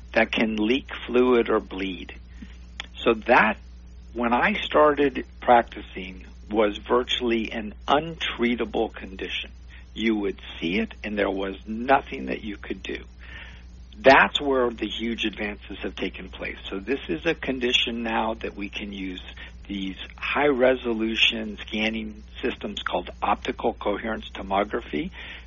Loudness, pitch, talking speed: -24 LUFS, 105 Hz, 130 wpm